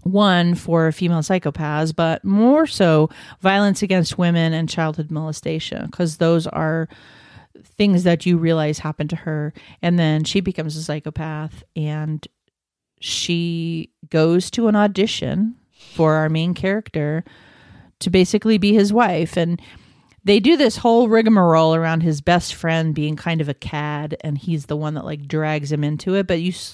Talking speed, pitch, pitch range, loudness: 160 wpm, 165 Hz, 155-185 Hz, -19 LUFS